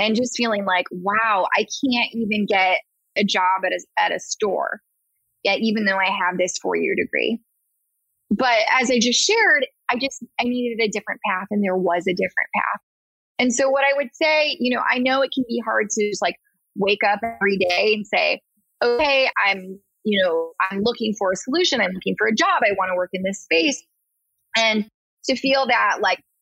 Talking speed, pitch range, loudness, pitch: 205 wpm, 195-255 Hz, -20 LUFS, 220 Hz